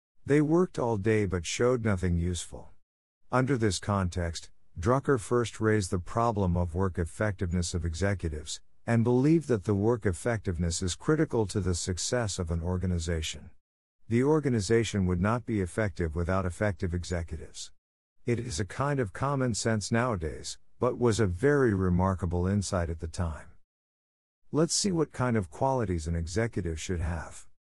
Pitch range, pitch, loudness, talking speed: 85-115 Hz, 95 Hz, -29 LUFS, 155 wpm